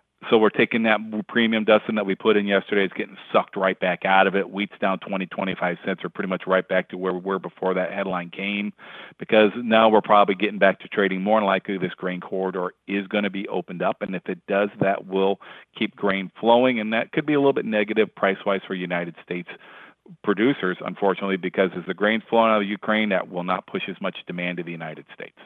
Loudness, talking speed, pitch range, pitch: -23 LUFS, 235 wpm, 95-110 Hz, 100 Hz